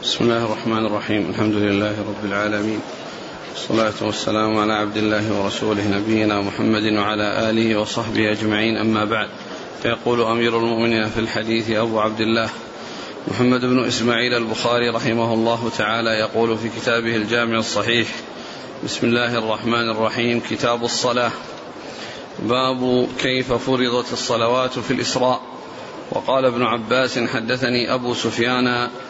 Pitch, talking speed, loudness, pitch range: 115 Hz, 125 wpm, -20 LUFS, 110-120 Hz